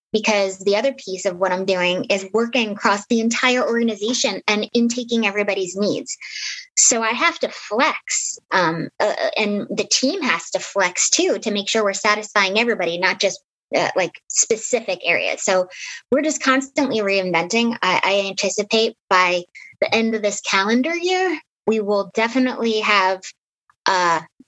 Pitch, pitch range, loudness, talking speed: 215 Hz, 200-255 Hz, -19 LUFS, 155 wpm